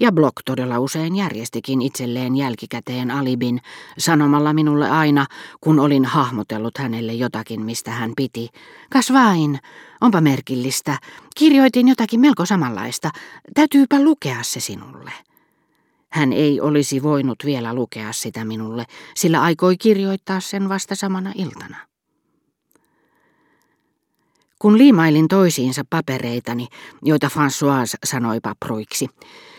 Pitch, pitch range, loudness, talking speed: 145 Hz, 125-190 Hz, -18 LUFS, 105 wpm